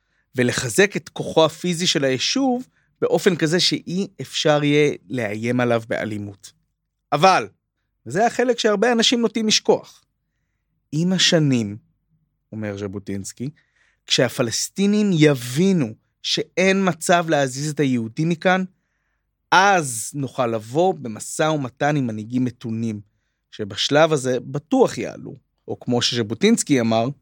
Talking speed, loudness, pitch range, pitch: 110 wpm, -20 LUFS, 120-180 Hz, 145 Hz